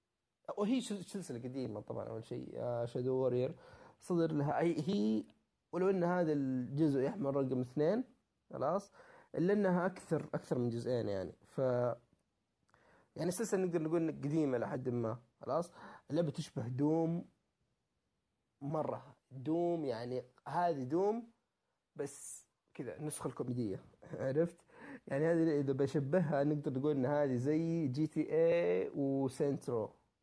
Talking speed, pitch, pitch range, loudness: 125 wpm, 150 Hz, 130-175 Hz, -37 LUFS